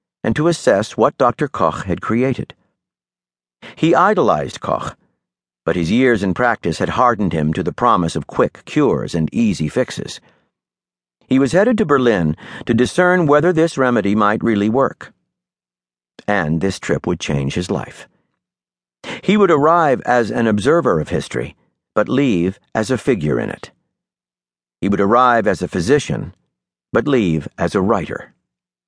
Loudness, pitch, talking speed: -17 LUFS, 95 Hz, 155 wpm